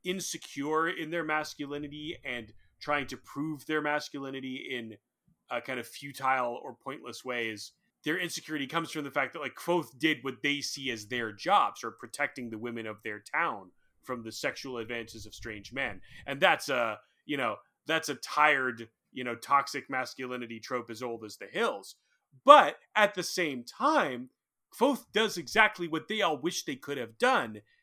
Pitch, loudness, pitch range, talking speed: 140 Hz, -30 LUFS, 120-160 Hz, 175 wpm